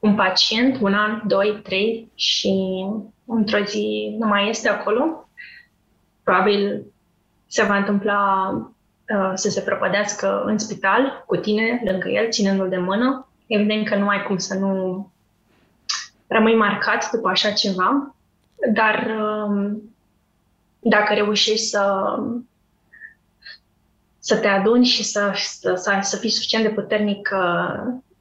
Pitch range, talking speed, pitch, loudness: 200-225 Hz, 125 wpm, 210 Hz, -20 LUFS